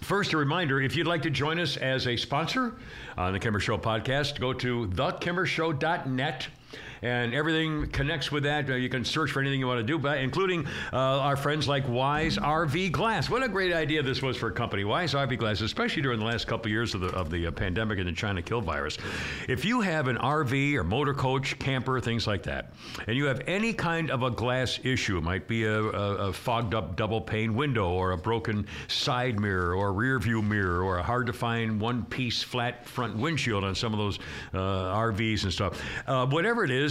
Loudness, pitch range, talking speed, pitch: -28 LUFS, 110-145 Hz, 220 wpm, 125 Hz